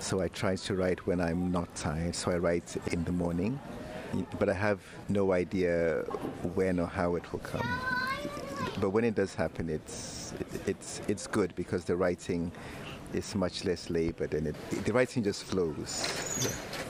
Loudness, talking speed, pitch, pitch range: -32 LUFS, 175 wpm, 90 Hz, 85-105 Hz